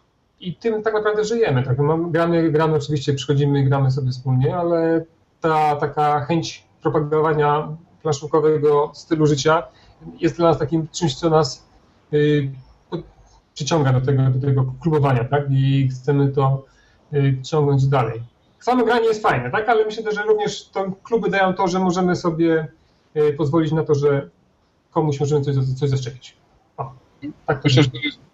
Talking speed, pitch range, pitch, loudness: 155 wpm, 140-165 Hz, 150 Hz, -19 LUFS